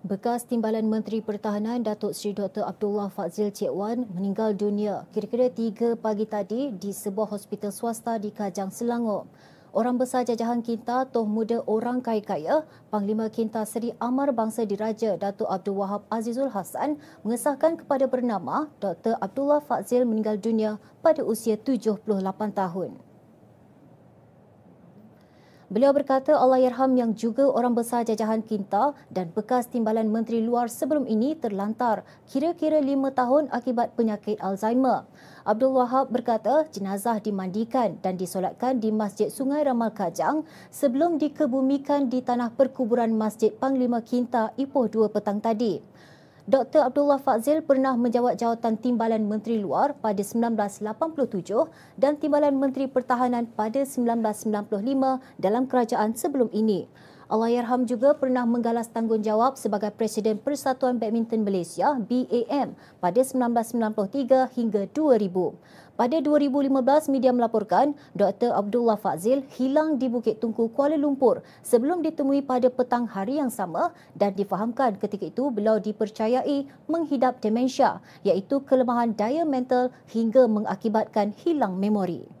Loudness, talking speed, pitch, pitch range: -25 LUFS, 130 wpm, 235 Hz, 215-260 Hz